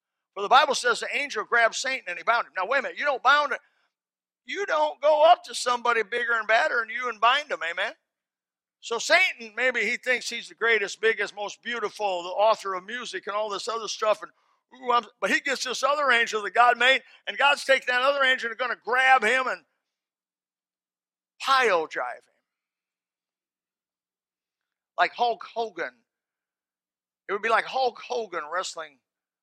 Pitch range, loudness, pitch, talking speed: 195-255 Hz, -24 LUFS, 230 Hz, 185 wpm